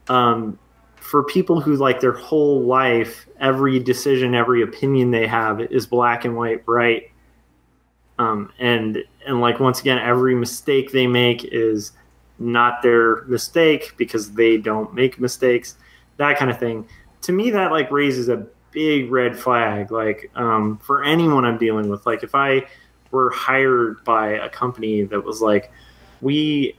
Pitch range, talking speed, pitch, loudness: 110-135 Hz, 155 wpm, 120 Hz, -19 LUFS